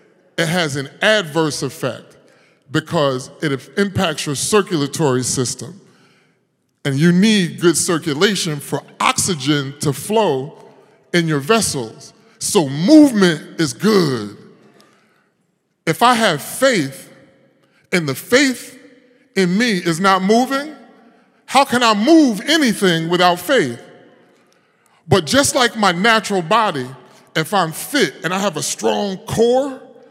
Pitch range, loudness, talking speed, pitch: 150-225 Hz, -16 LUFS, 120 wpm, 180 Hz